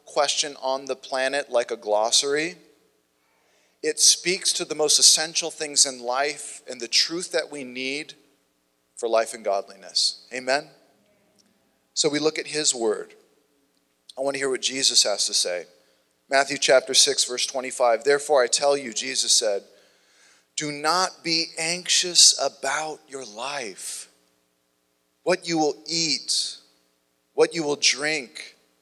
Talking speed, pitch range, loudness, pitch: 140 wpm, 120-155 Hz, -22 LUFS, 140 Hz